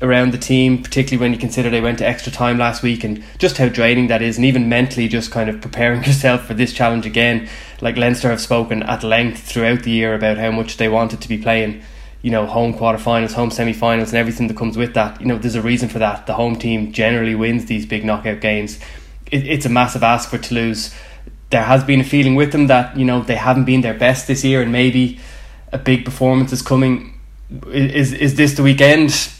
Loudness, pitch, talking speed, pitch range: -16 LUFS, 120 Hz, 230 wpm, 115-125 Hz